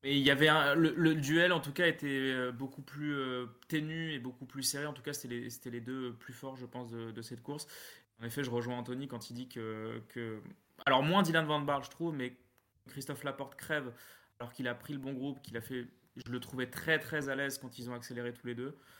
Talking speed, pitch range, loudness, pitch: 255 wpm, 120-145 Hz, -35 LUFS, 130 Hz